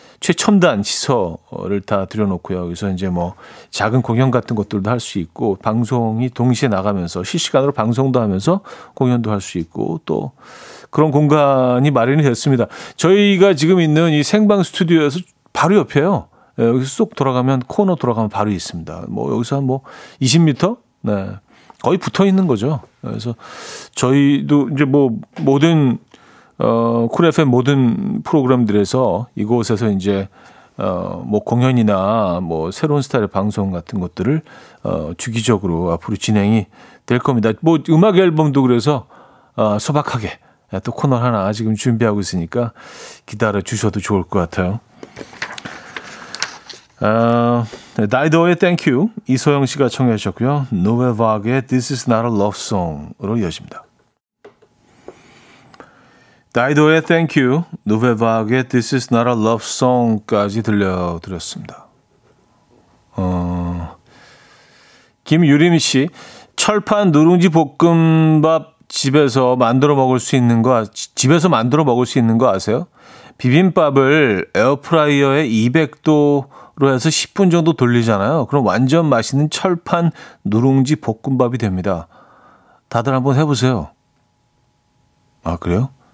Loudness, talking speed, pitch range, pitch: -16 LUFS, 300 characters per minute, 110-150 Hz, 125 Hz